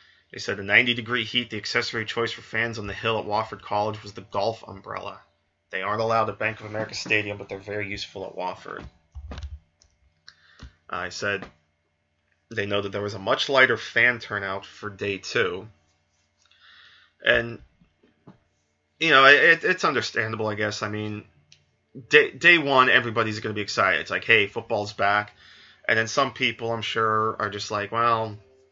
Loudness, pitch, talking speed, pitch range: -23 LUFS, 105 Hz, 175 wpm, 100-115 Hz